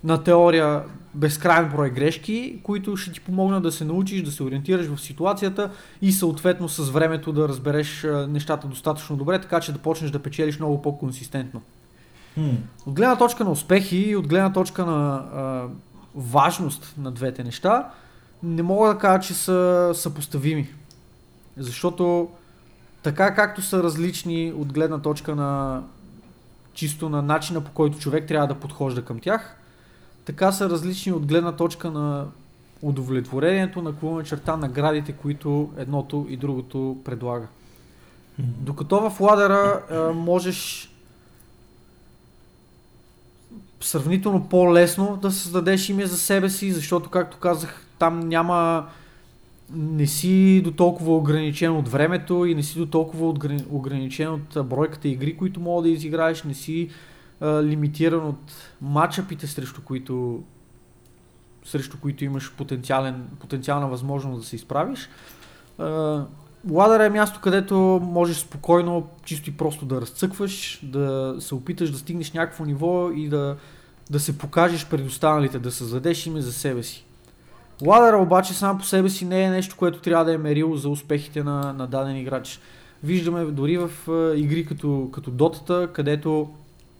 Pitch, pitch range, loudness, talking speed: 155 Hz, 140-175 Hz, -23 LUFS, 140 wpm